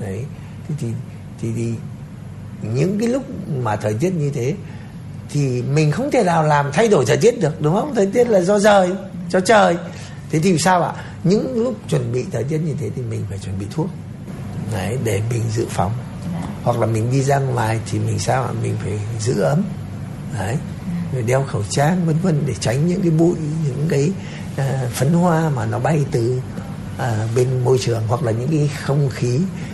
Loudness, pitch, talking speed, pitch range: -19 LUFS, 140 Hz, 200 wpm, 120-170 Hz